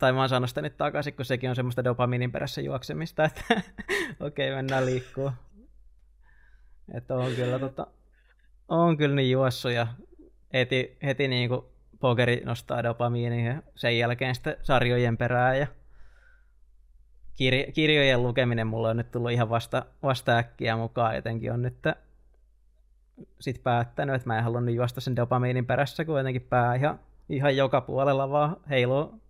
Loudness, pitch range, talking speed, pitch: -27 LUFS, 120-135 Hz, 150 wpm, 125 Hz